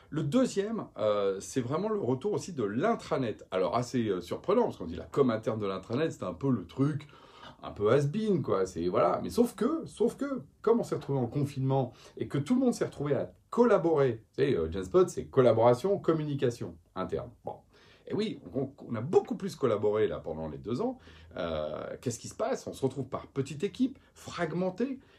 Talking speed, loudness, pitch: 205 wpm, -31 LUFS, 145 Hz